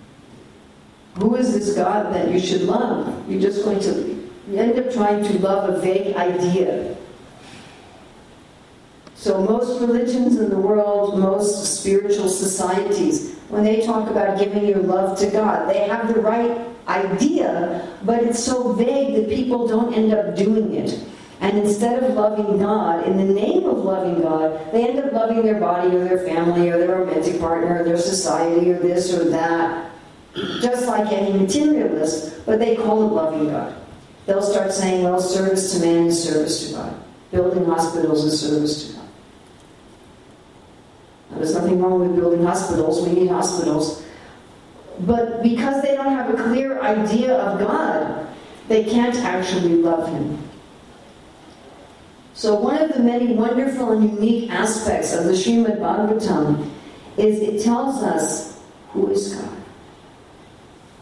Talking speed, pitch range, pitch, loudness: 155 wpm, 175-225 Hz, 200 Hz, -19 LUFS